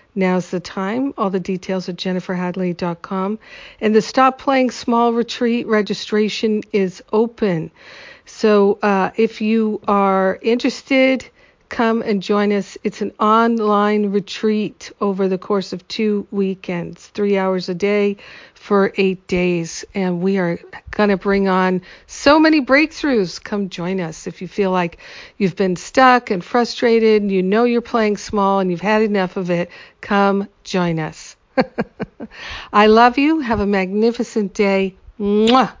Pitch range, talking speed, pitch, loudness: 190-225 Hz, 150 wpm, 205 Hz, -18 LUFS